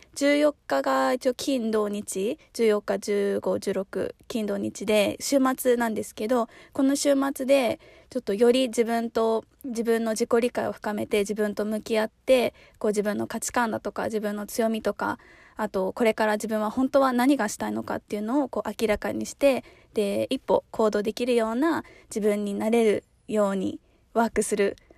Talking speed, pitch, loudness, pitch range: 310 characters per minute, 220 Hz, -26 LUFS, 210-250 Hz